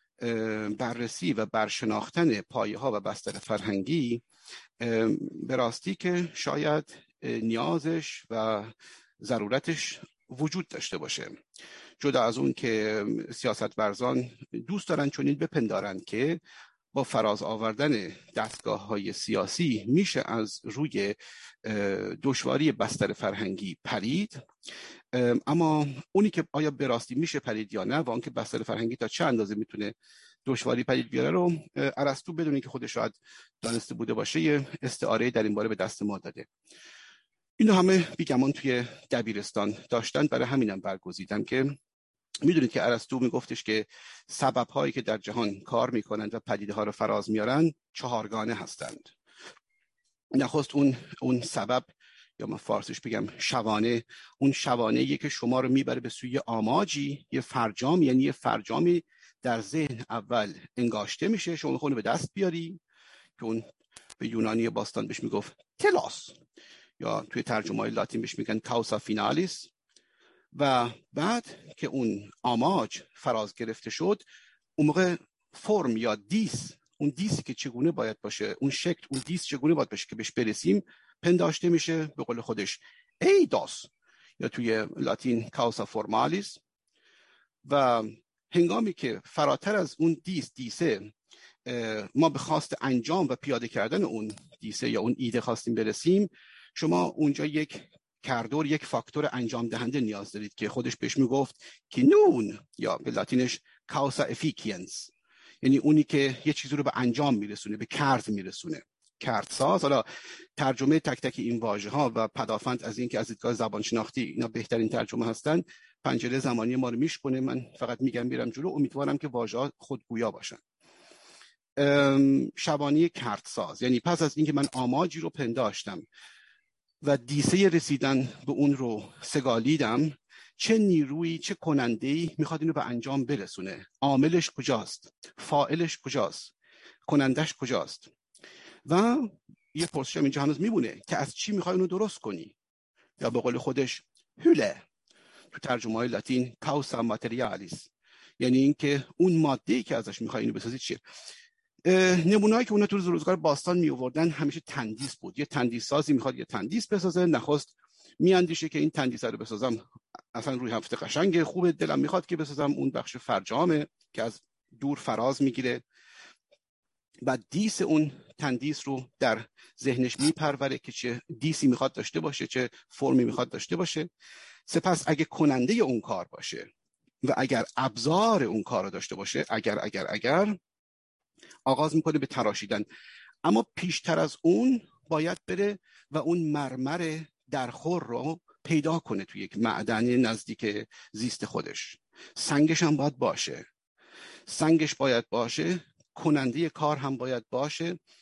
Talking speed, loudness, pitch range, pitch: 145 wpm, -29 LUFS, 115-160 Hz, 140 Hz